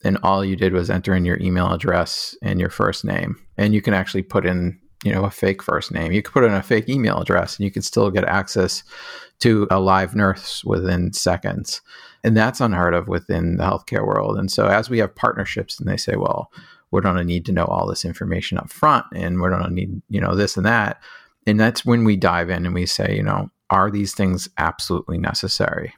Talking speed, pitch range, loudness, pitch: 230 wpm, 90-100 Hz, -20 LUFS, 95 Hz